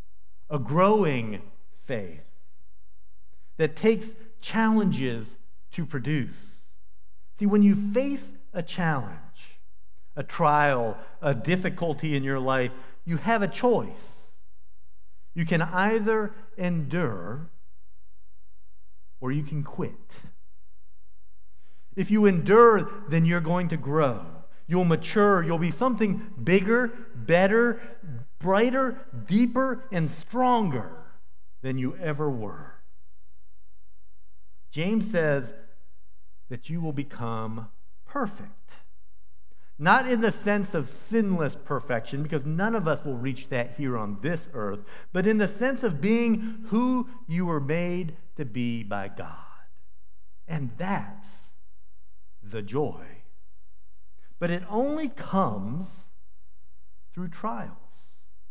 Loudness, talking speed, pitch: -26 LUFS, 110 wpm, 145 Hz